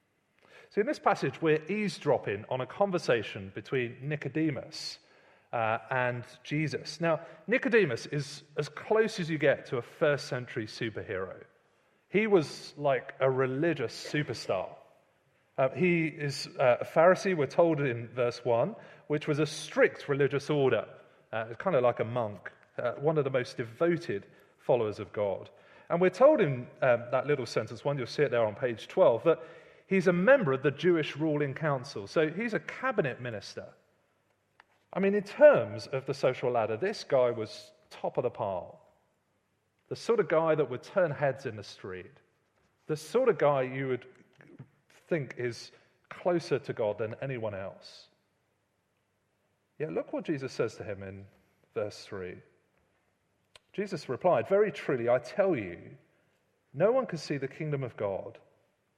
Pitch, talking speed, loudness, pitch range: 150 Hz, 165 wpm, -30 LUFS, 125-175 Hz